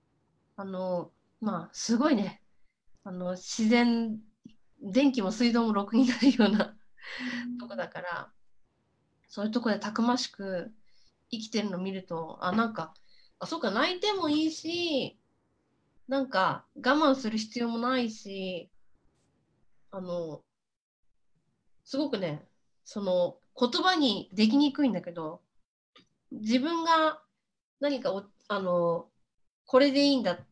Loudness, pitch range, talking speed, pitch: -29 LUFS, 195-265 Hz, 230 characters per minute, 230 Hz